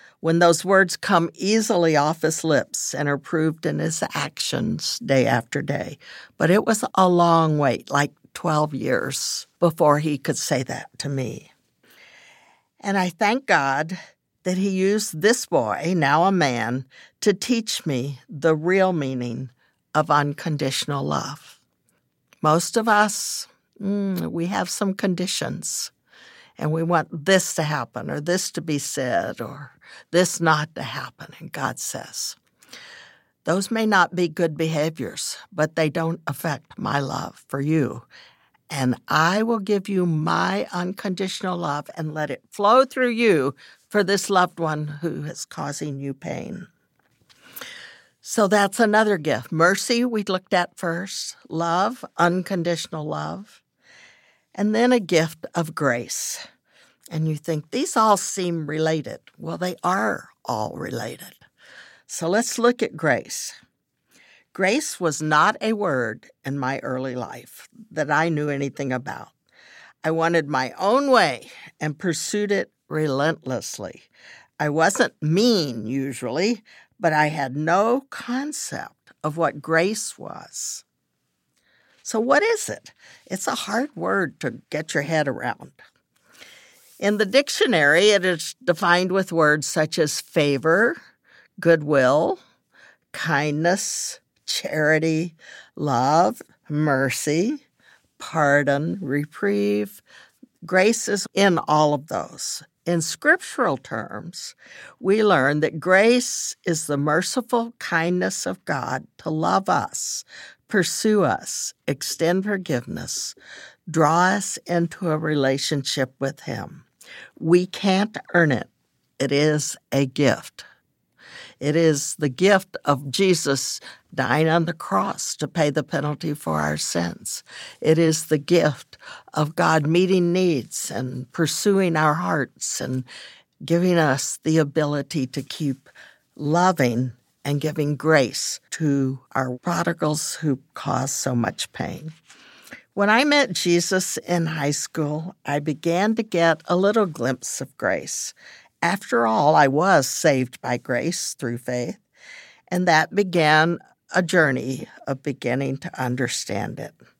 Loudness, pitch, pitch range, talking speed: -22 LUFS, 165 Hz, 145-190 Hz, 130 wpm